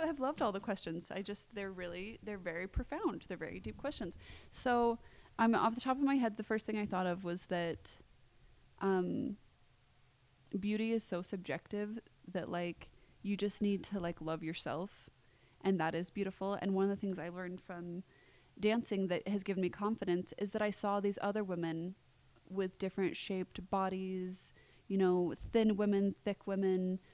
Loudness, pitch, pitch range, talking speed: -38 LUFS, 195 Hz, 175-205 Hz, 185 wpm